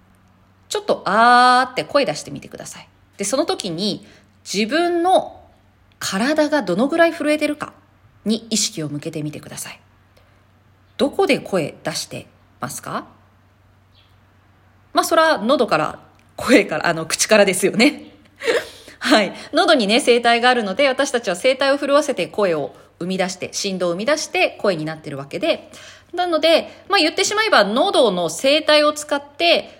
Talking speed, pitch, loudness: 300 characters per minute, 240 Hz, -18 LUFS